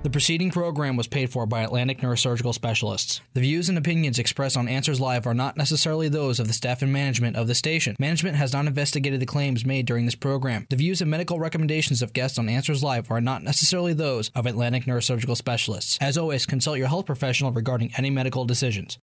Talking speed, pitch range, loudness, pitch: 215 wpm, 120-145 Hz, -23 LUFS, 130 Hz